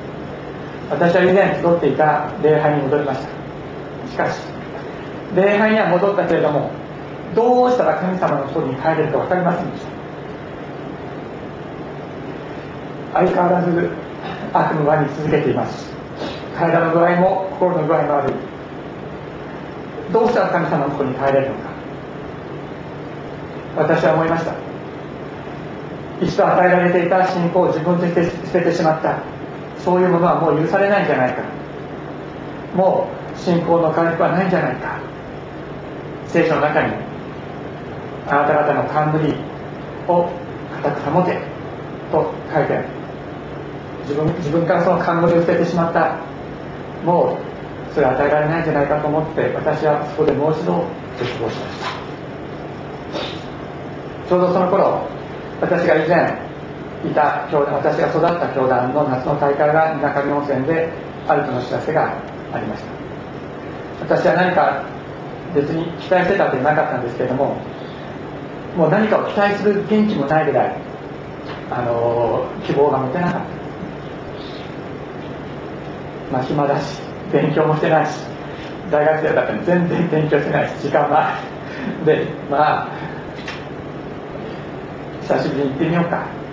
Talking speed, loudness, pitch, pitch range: 270 characters per minute, -18 LUFS, 155 Hz, 145-175 Hz